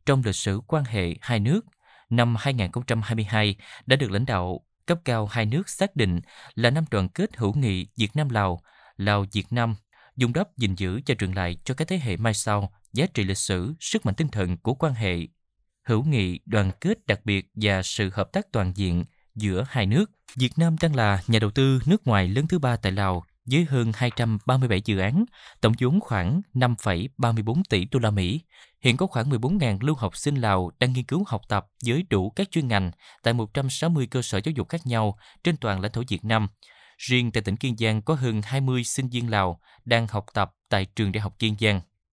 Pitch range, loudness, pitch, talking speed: 100-135 Hz, -25 LUFS, 115 Hz, 210 wpm